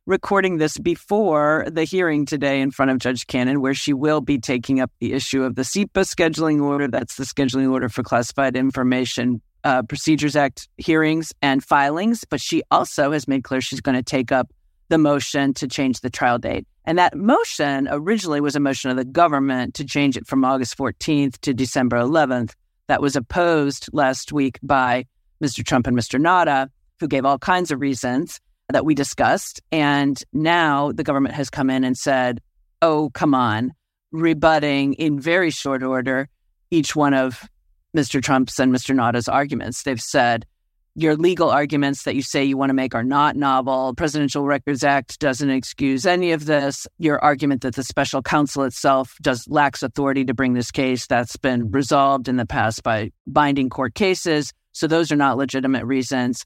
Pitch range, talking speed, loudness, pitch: 130-150 Hz, 185 wpm, -20 LUFS, 140 Hz